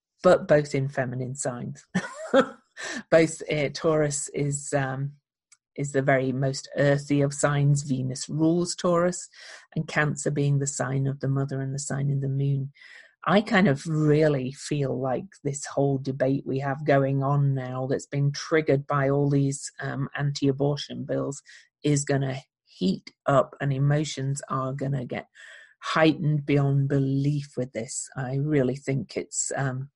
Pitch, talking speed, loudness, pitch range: 140 Hz, 155 wpm, -26 LUFS, 135-150 Hz